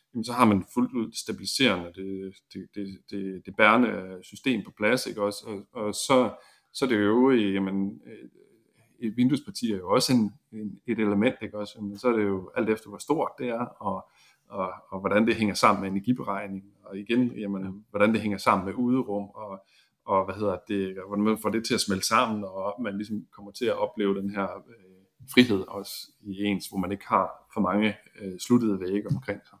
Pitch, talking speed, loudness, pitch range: 100 Hz, 215 wpm, -27 LUFS, 95-110 Hz